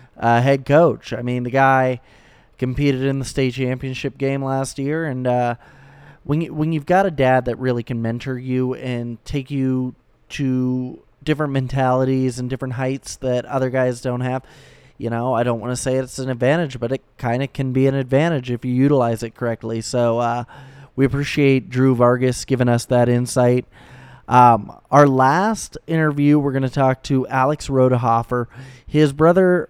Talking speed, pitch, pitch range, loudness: 180 wpm, 130 Hz, 125-140 Hz, -19 LUFS